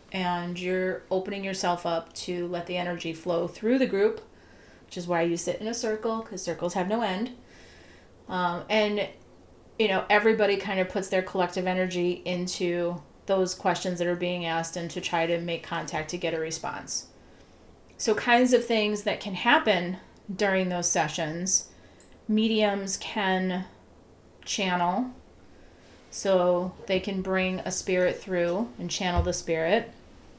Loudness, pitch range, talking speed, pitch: -27 LUFS, 170-200 Hz, 155 wpm, 180 Hz